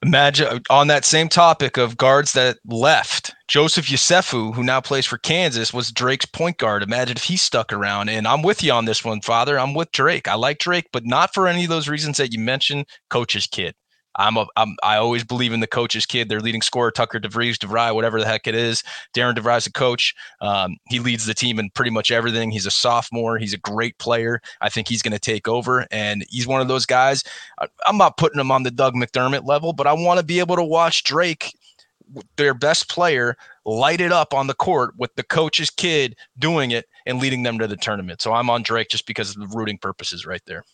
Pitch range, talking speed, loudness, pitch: 115-140 Hz, 235 wpm, -19 LUFS, 120 Hz